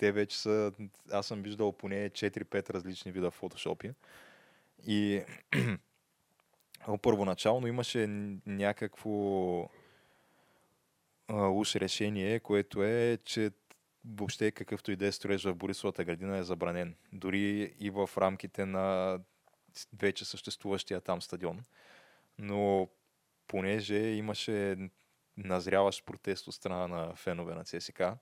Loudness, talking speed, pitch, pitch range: -34 LUFS, 105 wpm, 100 Hz, 95-105 Hz